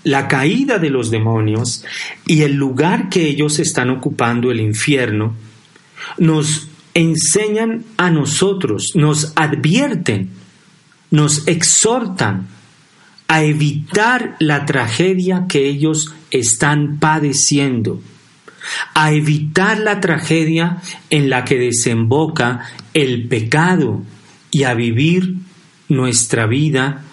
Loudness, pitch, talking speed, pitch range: -15 LUFS, 150 Hz, 100 wpm, 130-170 Hz